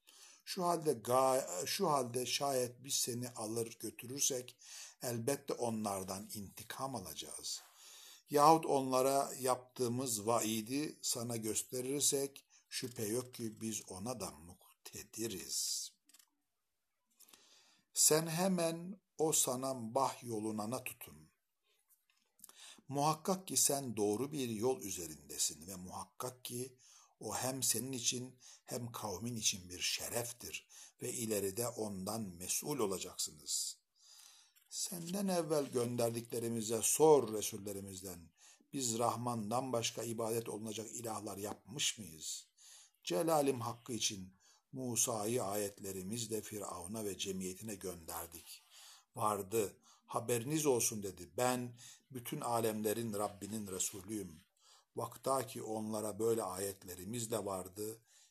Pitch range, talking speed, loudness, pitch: 105-130 Hz, 100 wpm, -38 LUFS, 115 Hz